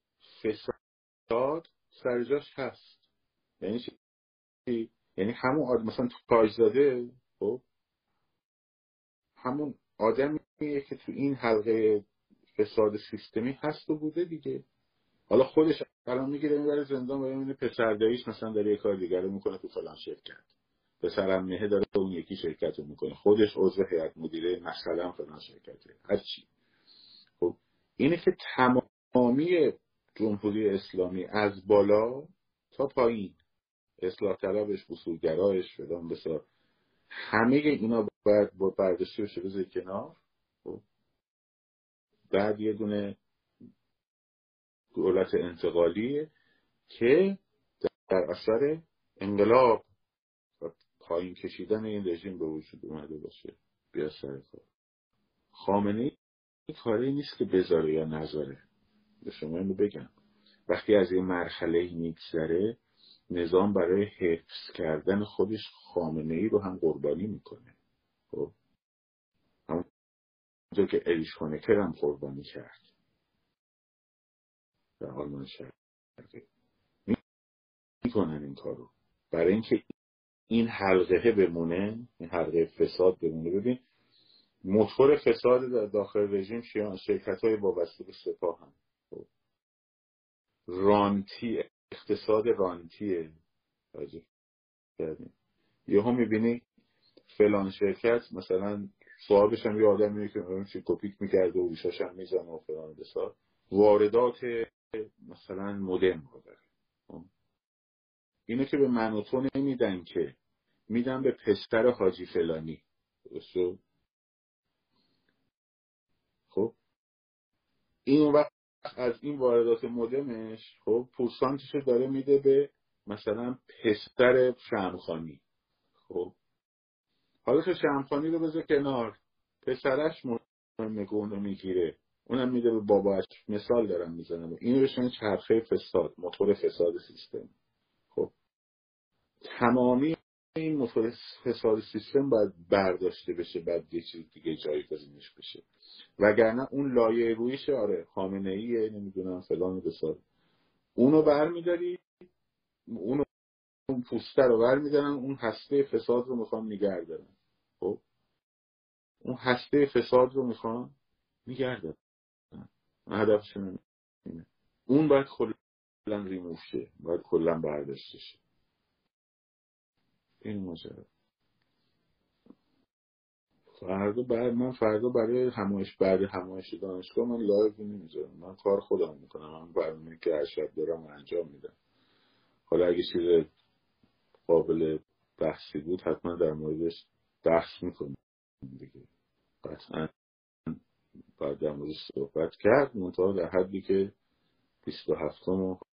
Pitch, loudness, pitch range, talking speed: 110 Hz, -29 LUFS, 90-140 Hz, 110 wpm